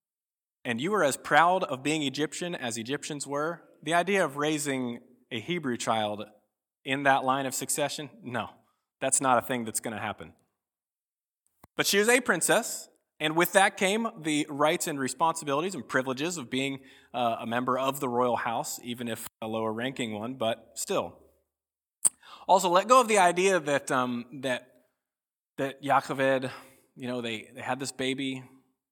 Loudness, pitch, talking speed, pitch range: -28 LUFS, 135 Hz, 170 wpm, 125-155 Hz